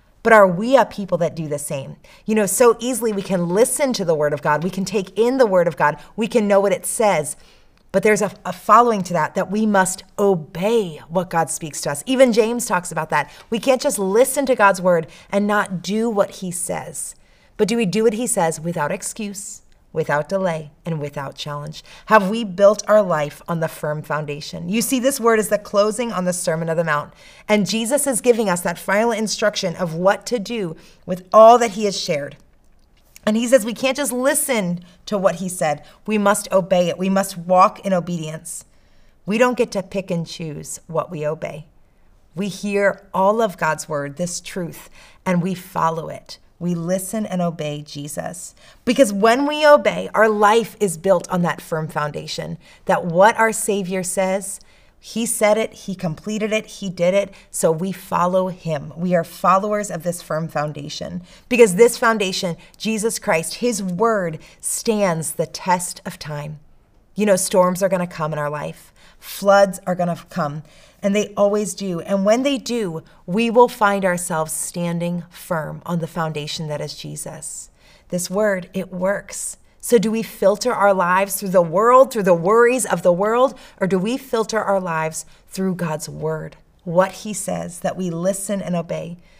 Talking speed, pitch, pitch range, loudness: 195 wpm, 190 Hz, 170-215 Hz, -19 LUFS